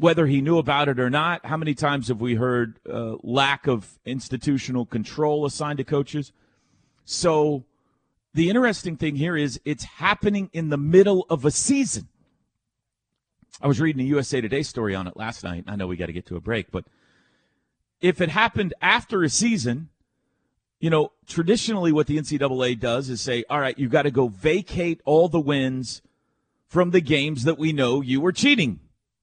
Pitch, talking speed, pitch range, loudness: 145 Hz, 185 wpm, 125-165 Hz, -23 LUFS